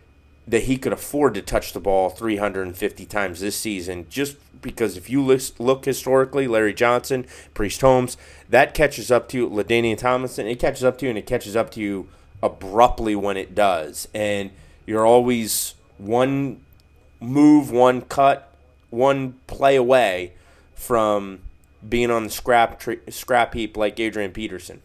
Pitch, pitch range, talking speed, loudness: 115 Hz, 95-125 Hz, 155 wpm, -21 LUFS